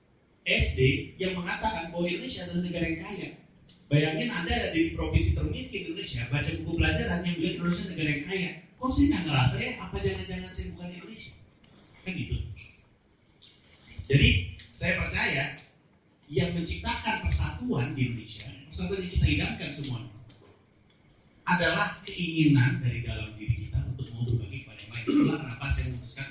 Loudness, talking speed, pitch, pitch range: -29 LUFS, 155 wpm, 135 Hz, 110-170 Hz